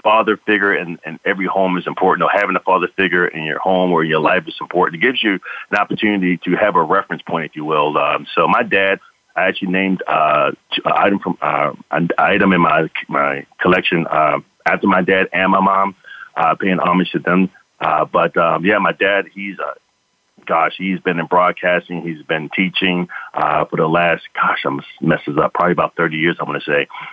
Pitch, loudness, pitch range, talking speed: 95 Hz, -16 LUFS, 90-95 Hz, 210 wpm